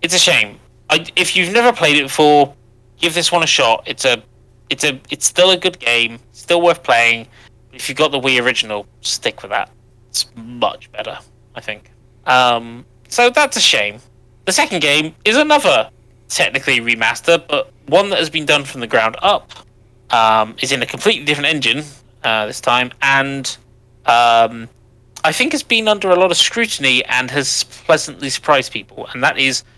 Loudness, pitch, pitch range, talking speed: -14 LUFS, 130 Hz, 120-160 Hz, 185 wpm